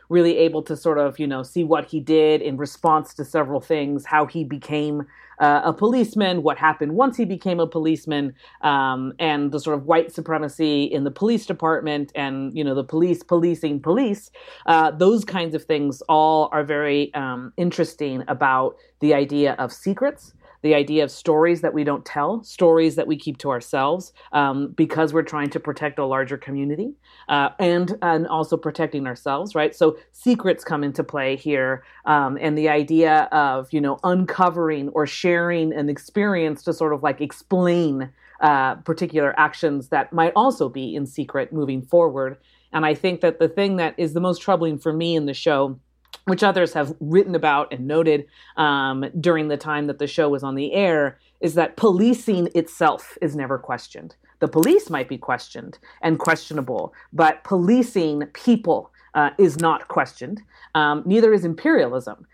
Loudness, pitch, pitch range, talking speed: -21 LUFS, 155 Hz, 145-170 Hz, 180 wpm